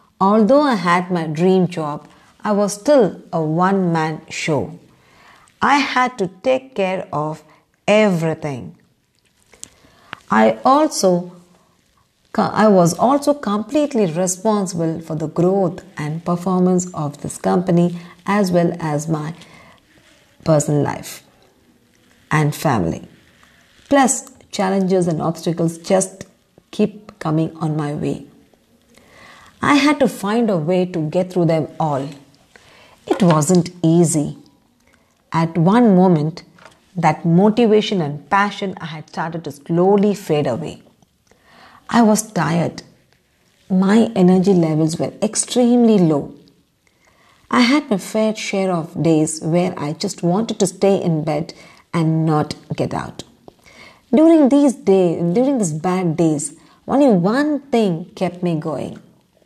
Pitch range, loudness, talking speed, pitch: 160-210 Hz, -17 LUFS, 120 wpm, 180 Hz